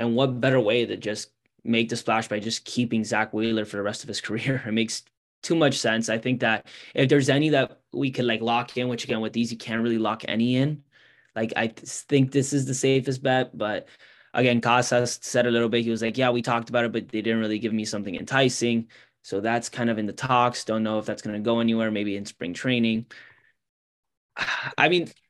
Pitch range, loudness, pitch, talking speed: 110-125 Hz, -25 LUFS, 115 Hz, 235 wpm